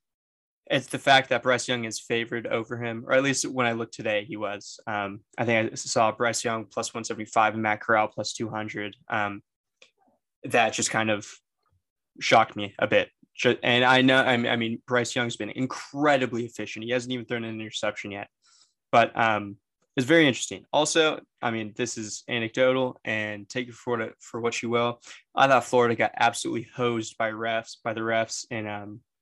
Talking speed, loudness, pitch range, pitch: 185 wpm, -25 LUFS, 110-125 Hz, 115 Hz